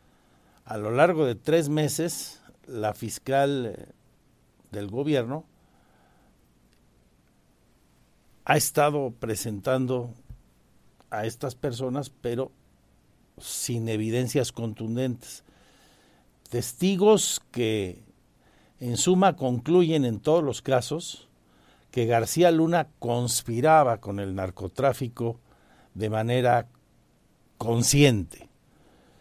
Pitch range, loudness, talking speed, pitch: 110-145 Hz, -25 LUFS, 80 wpm, 125 Hz